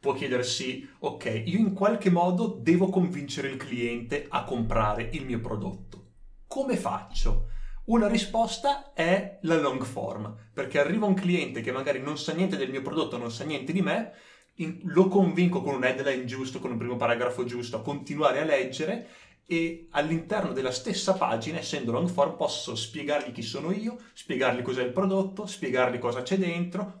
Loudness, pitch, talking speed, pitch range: -28 LUFS, 145 Hz, 170 wpm, 125-190 Hz